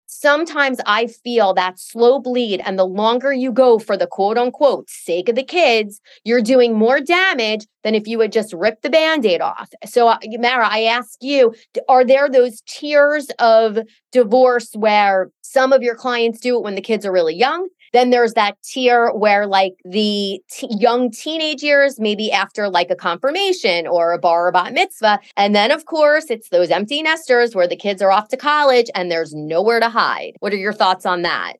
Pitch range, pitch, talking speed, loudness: 205-265 Hz, 230 Hz, 200 wpm, -16 LUFS